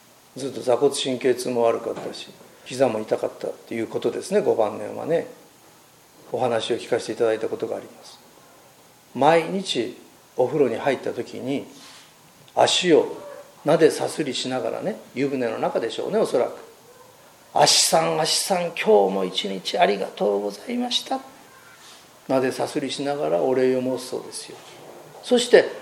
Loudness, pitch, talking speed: -22 LUFS, 165 Hz, 305 characters per minute